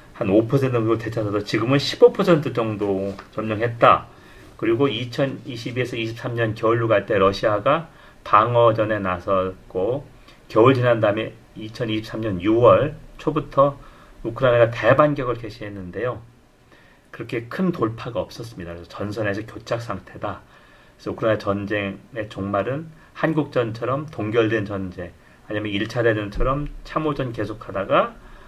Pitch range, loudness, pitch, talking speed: 105-130 Hz, -21 LUFS, 115 Hz, 275 characters per minute